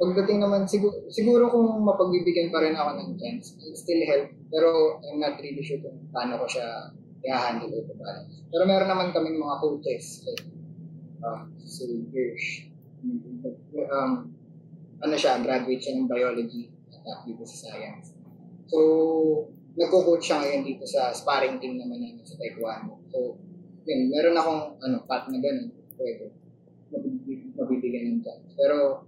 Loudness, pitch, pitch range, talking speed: -26 LUFS, 160 Hz, 140-200 Hz, 150 wpm